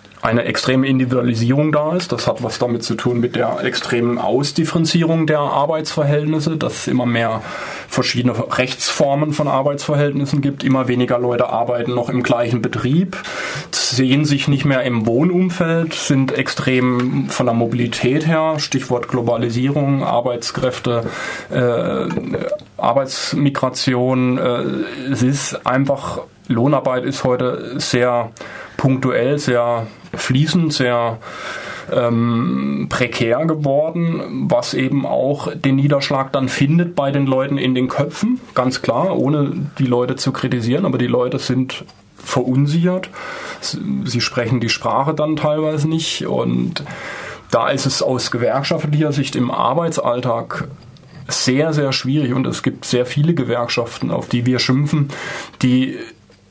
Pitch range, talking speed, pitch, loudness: 125-150 Hz, 130 wpm, 130 Hz, -18 LUFS